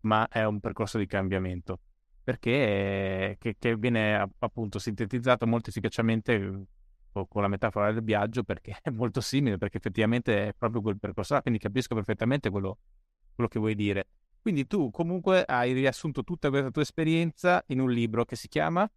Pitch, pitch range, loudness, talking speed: 115 Hz, 100-125 Hz, -29 LUFS, 170 wpm